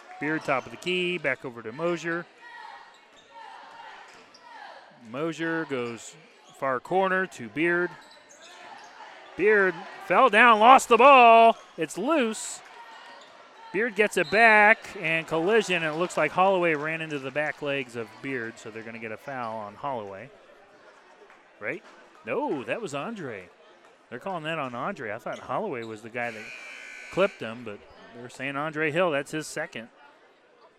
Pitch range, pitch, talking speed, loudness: 135-220 Hz, 165 Hz, 150 wpm, -24 LUFS